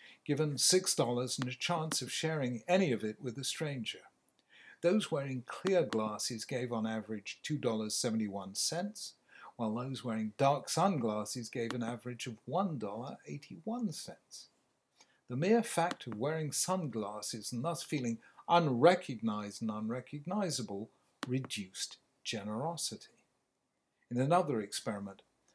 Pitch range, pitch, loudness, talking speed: 110-165 Hz, 125 Hz, -35 LUFS, 115 wpm